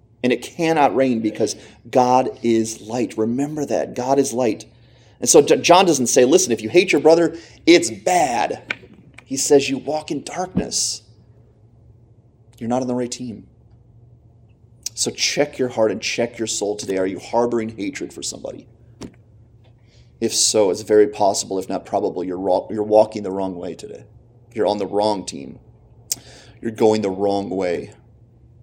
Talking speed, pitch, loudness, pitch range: 165 wpm, 115 Hz, -19 LUFS, 110-125 Hz